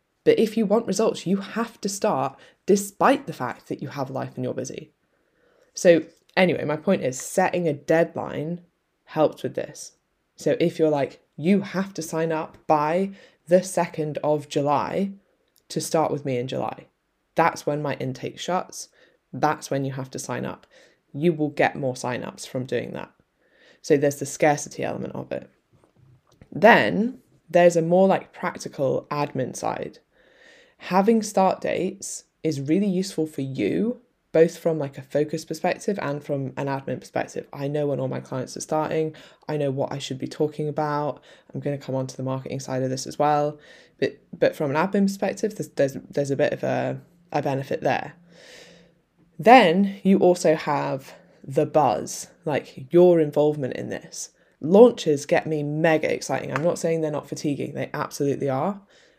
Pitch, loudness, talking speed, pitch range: 155 Hz, -24 LUFS, 175 wpm, 145-185 Hz